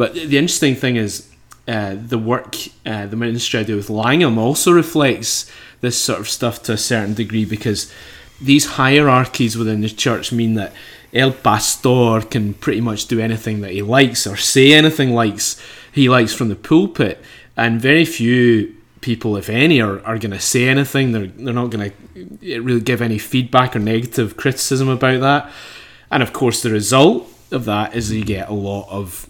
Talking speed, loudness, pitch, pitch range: 190 wpm, -16 LUFS, 115 Hz, 110-130 Hz